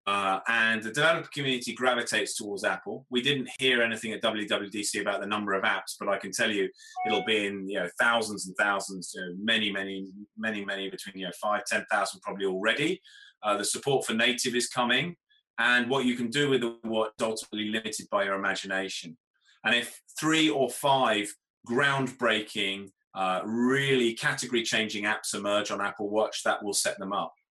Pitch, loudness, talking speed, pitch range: 110 Hz, -28 LUFS, 190 wpm, 100-125 Hz